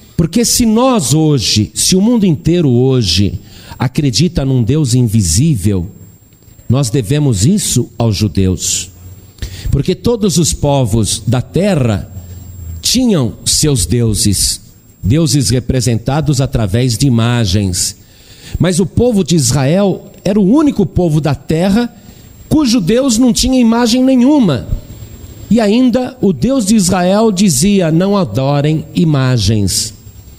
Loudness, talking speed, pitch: -12 LUFS, 115 wpm, 135 Hz